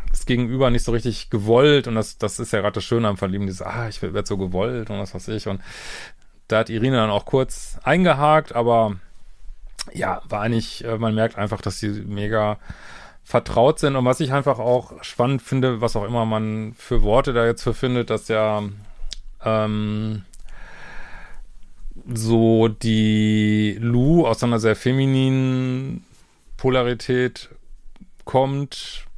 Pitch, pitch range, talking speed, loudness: 115 Hz, 105-125 Hz, 150 wpm, -21 LUFS